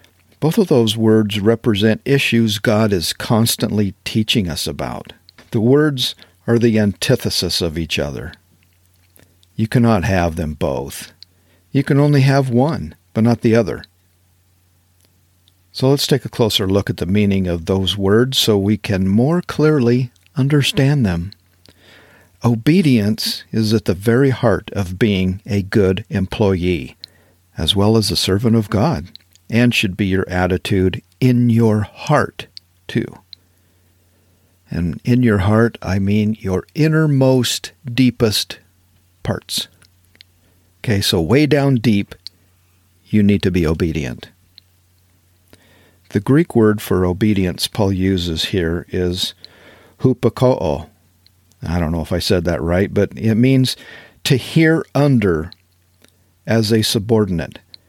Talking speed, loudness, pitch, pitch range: 130 wpm, -17 LUFS, 100 Hz, 90-115 Hz